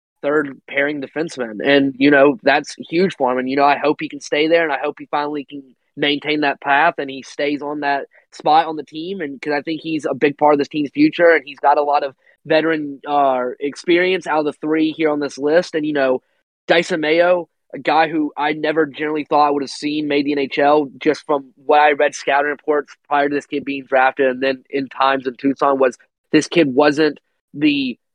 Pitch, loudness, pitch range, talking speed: 145 Hz, -17 LUFS, 140-155 Hz, 230 wpm